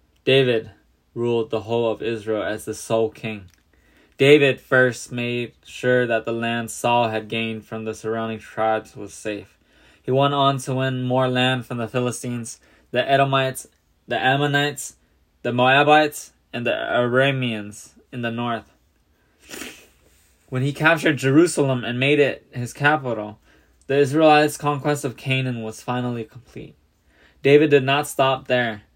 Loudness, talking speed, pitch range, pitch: -21 LUFS, 145 wpm, 110-135 Hz, 120 Hz